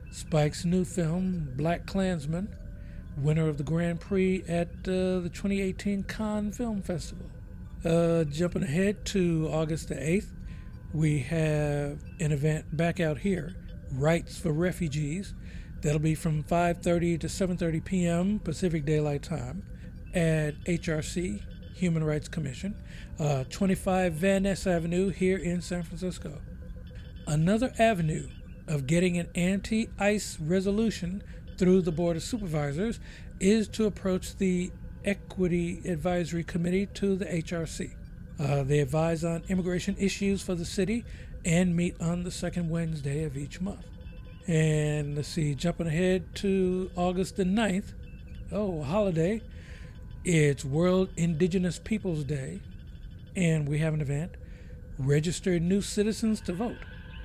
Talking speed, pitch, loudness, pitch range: 130 wpm, 170 Hz, -29 LUFS, 155-185 Hz